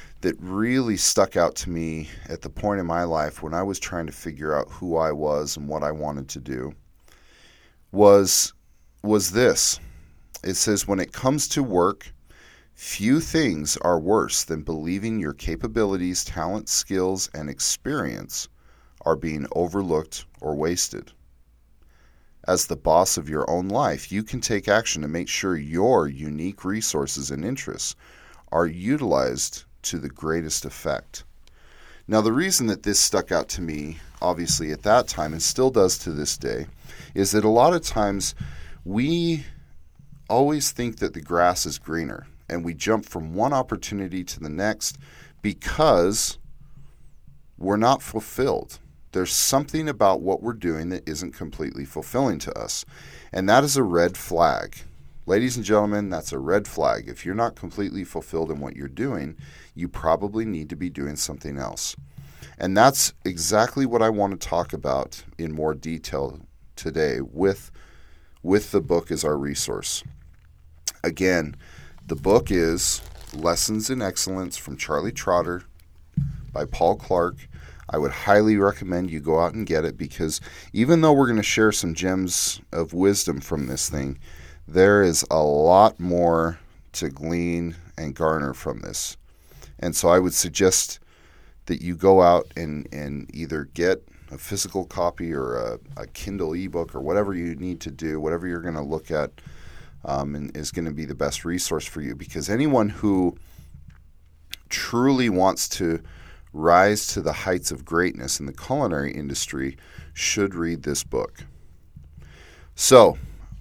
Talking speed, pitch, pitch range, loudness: 160 wpm, 85 Hz, 75-95 Hz, -23 LUFS